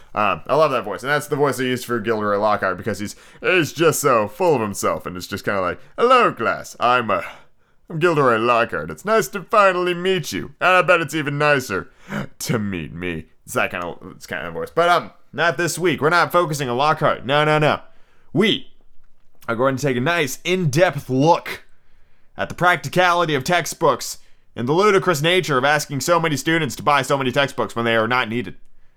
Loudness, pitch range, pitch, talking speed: -19 LUFS, 120-175 Hz, 145 Hz, 215 wpm